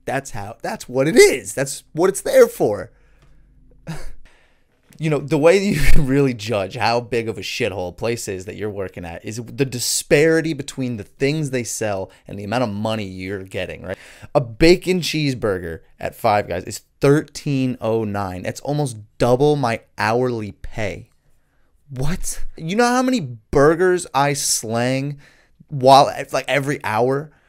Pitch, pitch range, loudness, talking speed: 130 Hz, 110-150 Hz, -19 LUFS, 160 wpm